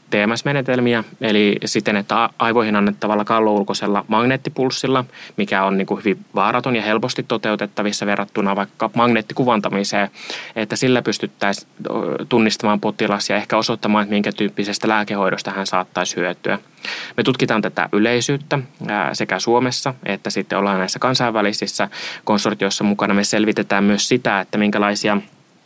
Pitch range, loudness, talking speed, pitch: 100-120 Hz, -19 LUFS, 125 wpm, 105 Hz